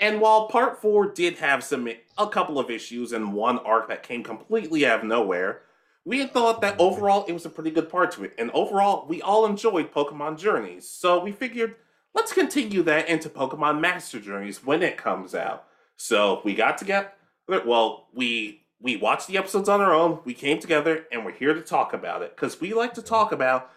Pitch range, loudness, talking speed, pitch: 135-220 Hz, -24 LUFS, 210 wpm, 175 Hz